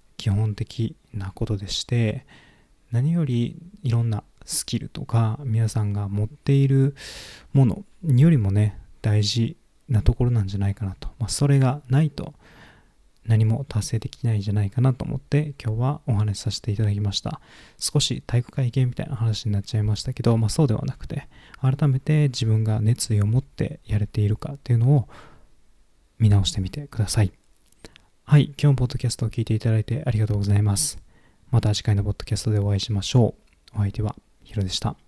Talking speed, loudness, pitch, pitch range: 380 characters per minute, -23 LUFS, 115 Hz, 105-135 Hz